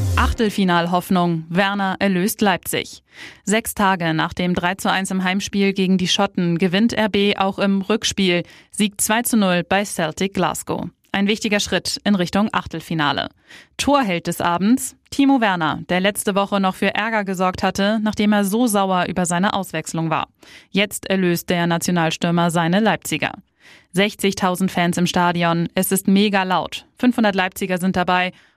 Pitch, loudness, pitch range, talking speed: 190 Hz, -19 LUFS, 175-205 Hz, 145 wpm